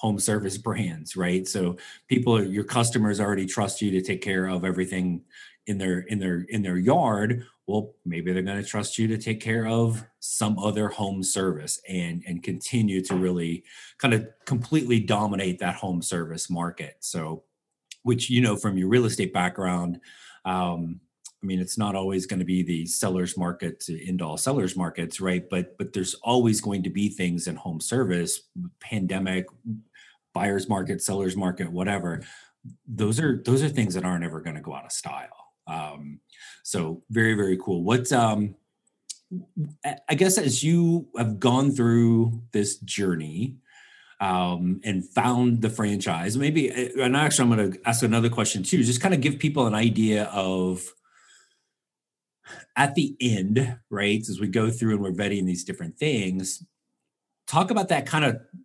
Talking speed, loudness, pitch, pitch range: 170 wpm, -25 LUFS, 105 Hz, 90-120 Hz